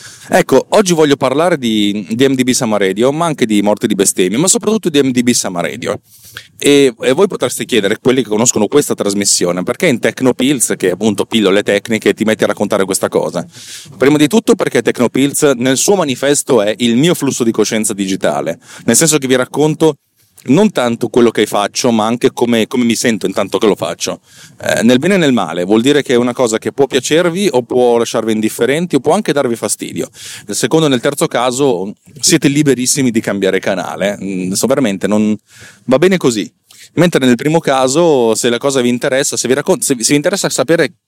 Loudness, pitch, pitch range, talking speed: -12 LUFS, 125 Hz, 115-145 Hz, 200 wpm